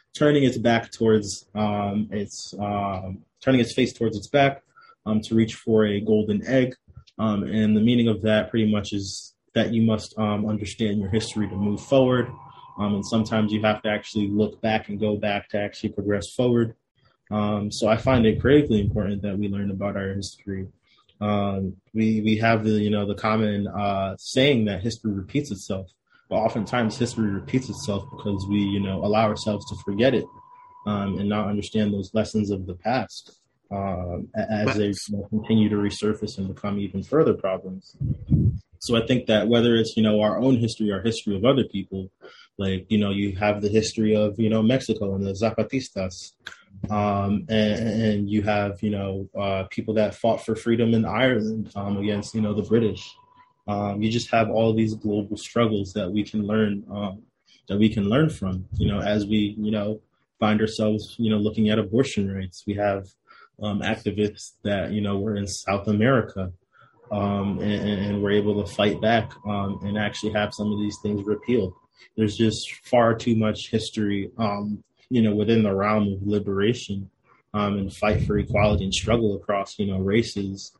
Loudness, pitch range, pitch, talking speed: -24 LUFS, 100-110 Hz, 105 Hz, 190 wpm